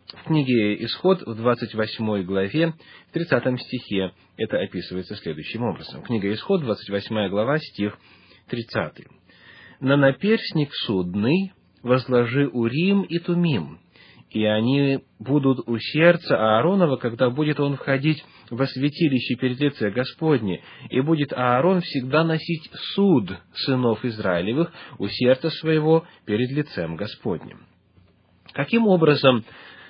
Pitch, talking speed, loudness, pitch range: 130 Hz, 115 wpm, -22 LUFS, 110-155 Hz